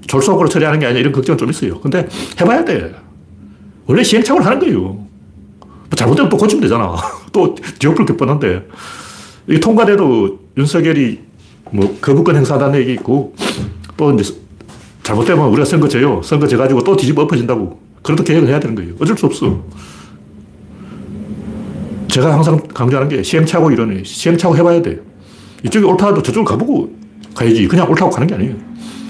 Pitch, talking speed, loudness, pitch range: 140 Hz, 375 characters per minute, -13 LUFS, 110-170 Hz